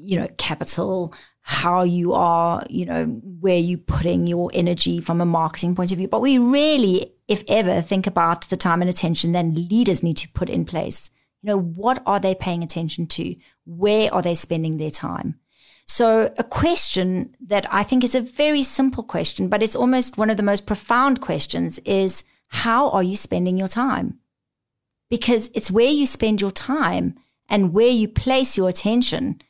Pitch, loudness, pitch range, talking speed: 195 Hz, -20 LUFS, 175-235 Hz, 185 wpm